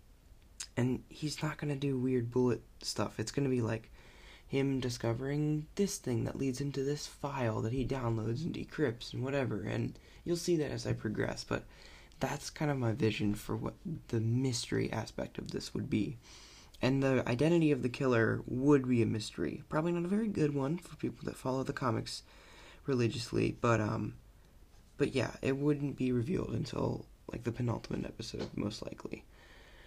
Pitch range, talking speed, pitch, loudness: 115-140 Hz, 180 wpm, 125 Hz, -35 LUFS